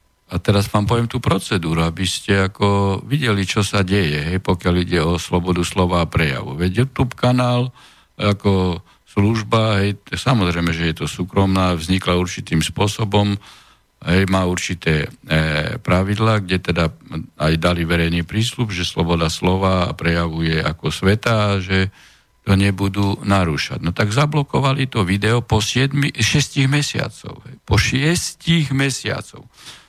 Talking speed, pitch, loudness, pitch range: 140 wpm, 100 Hz, -18 LUFS, 90-110 Hz